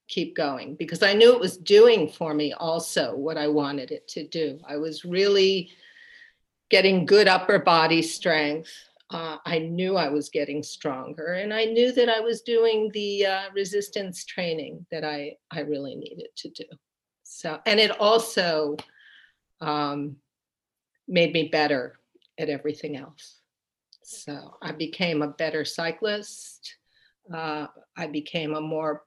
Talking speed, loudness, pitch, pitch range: 150 wpm, -24 LUFS, 165 Hz, 150-205 Hz